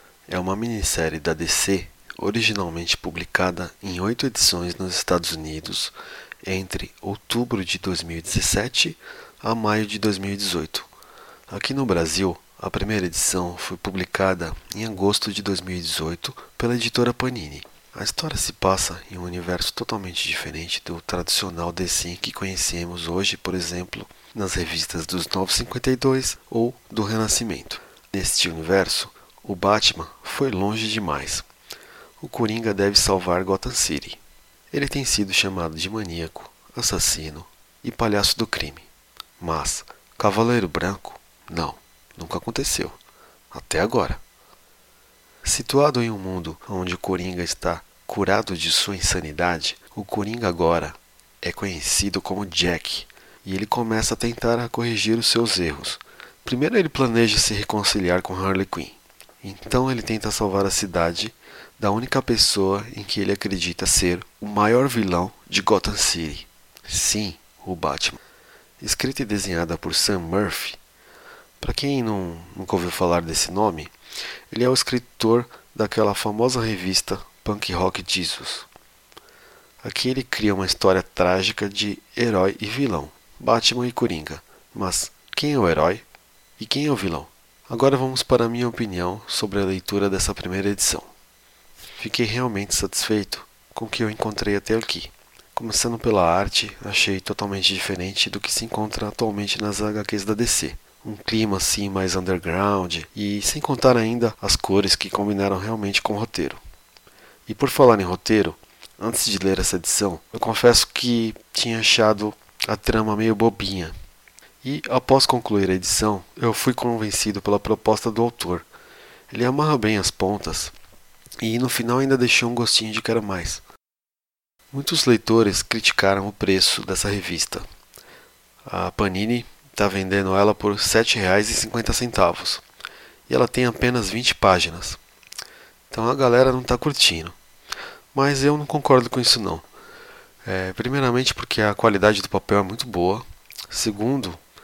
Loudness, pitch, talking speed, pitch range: -22 LUFS, 100 Hz, 145 wpm, 90-115 Hz